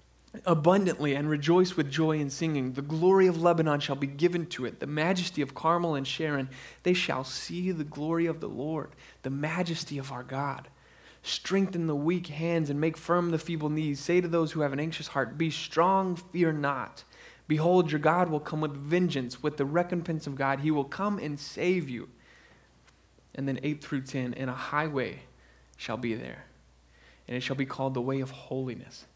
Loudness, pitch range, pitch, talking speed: -29 LUFS, 135-170 Hz, 150 Hz, 195 wpm